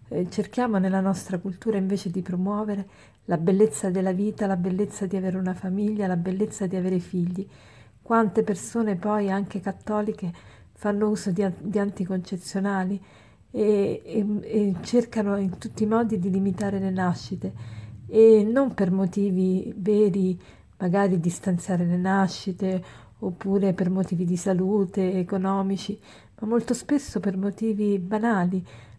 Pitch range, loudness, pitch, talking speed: 185-210 Hz, -25 LUFS, 195 Hz, 135 wpm